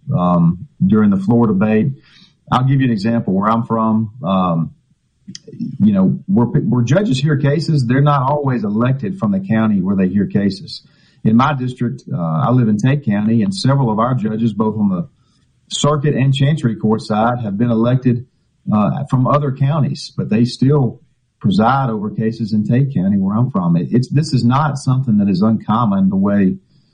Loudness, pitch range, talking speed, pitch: -16 LUFS, 110-145 Hz, 185 wpm, 125 Hz